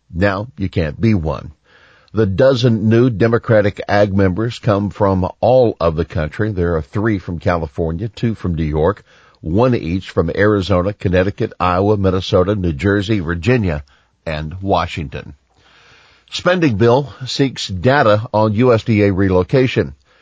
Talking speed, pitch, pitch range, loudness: 135 wpm, 100 Hz, 90-115 Hz, -16 LUFS